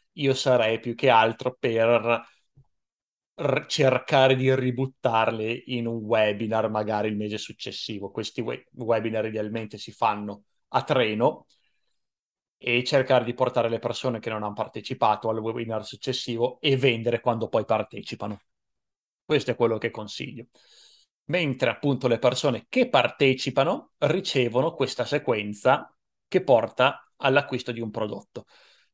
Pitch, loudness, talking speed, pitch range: 120 Hz, -25 LUFS, 130 wpm, 110-130 Hz